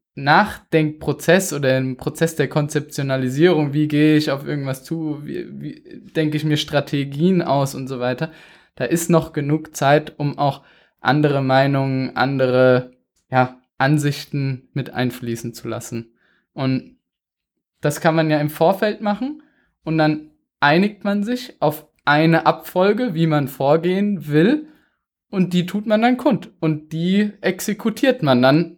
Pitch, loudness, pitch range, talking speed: 150 Hz, -19 LUFS, 135-175 Hz, 145 wpm